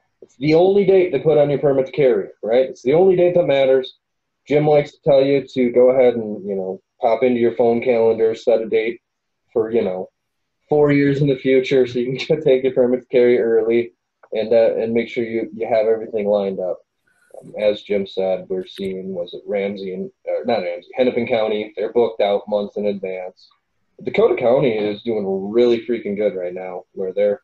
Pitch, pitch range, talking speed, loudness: 125 Hz, 105-155 Hz, 210 wpm, -18 LUFS